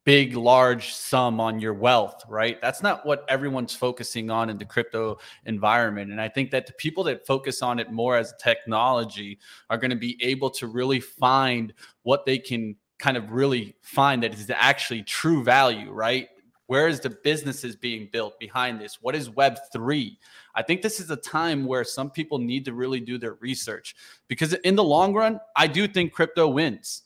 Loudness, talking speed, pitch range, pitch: -24 LUFS, 195 wpm, 115-140 Hz, 125 Hz